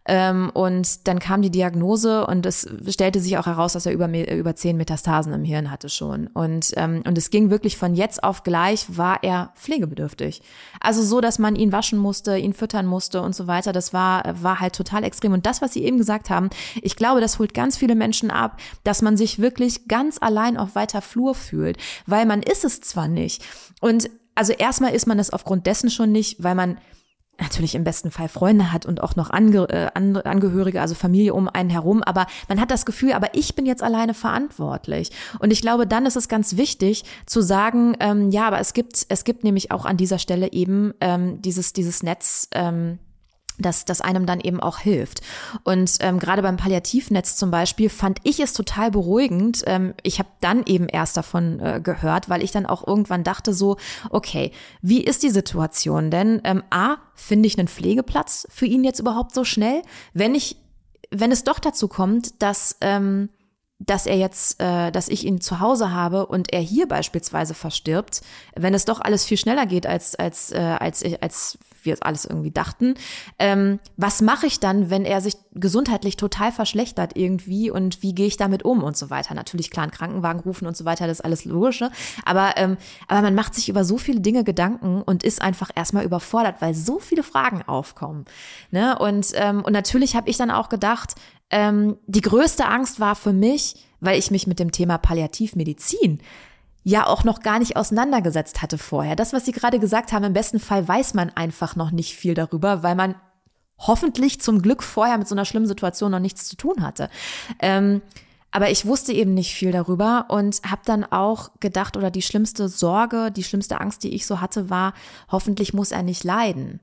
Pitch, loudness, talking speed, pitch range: 200 Hz, -21 LUFS, 200 wpm, 185-225 Hz